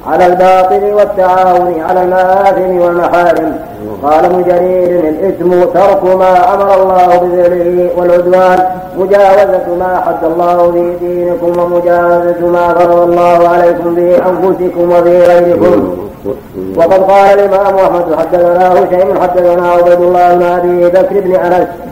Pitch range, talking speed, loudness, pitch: 175-185 Hz, 110 wpm, -8 LUFS, 180 Hz